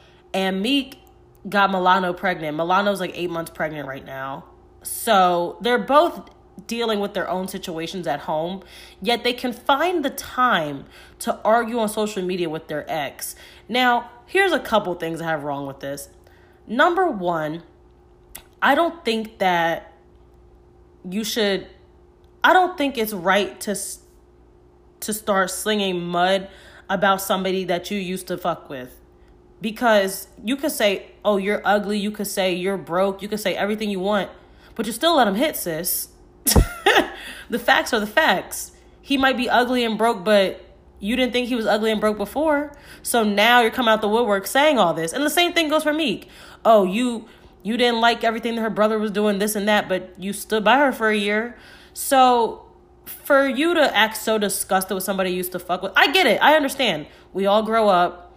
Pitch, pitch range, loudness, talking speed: 205 Hz, 185-240 Hz, -20 LUFS, 185 wpm